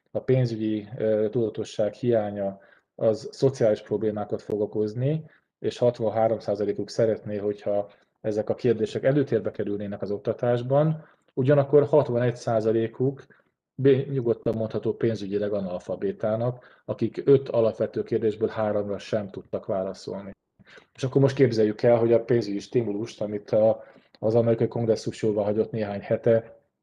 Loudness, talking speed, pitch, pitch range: -25 LUFS, 110 wpm, 110 Hz, 105-120 Hz